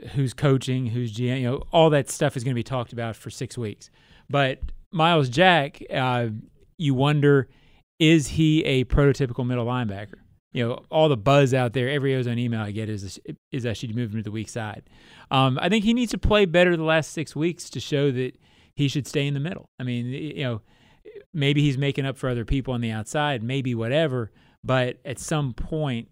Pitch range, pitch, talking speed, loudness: 120-150 Hz, 135 Hz, 215 wpm, -24 LUFS